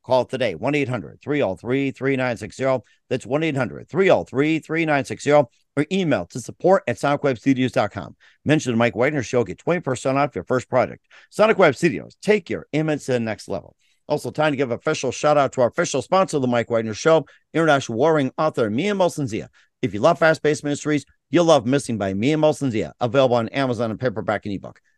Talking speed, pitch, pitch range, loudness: 185 wpm, 135 Hz, 125-155 Hz, -21 LUFS